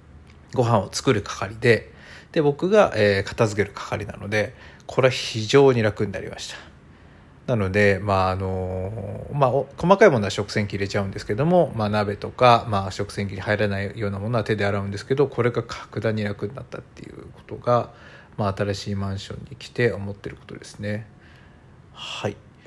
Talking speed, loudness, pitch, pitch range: 355 characters per minute, -23 LUFS, 105 Hz, 100-120 Hz